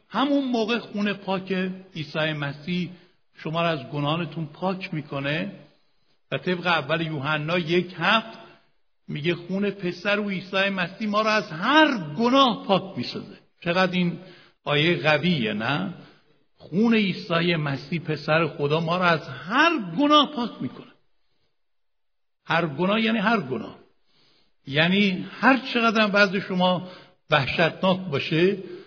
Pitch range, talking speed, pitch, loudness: 160-205 Hz, 125 wpm, 180 Hz, -23 LUFS